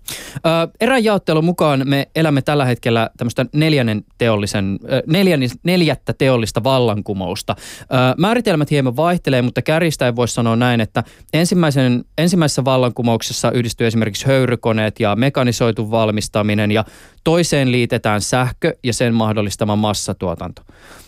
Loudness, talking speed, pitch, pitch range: -16 LUFS, 105 wpm, 125 Hz, 110-145 Hz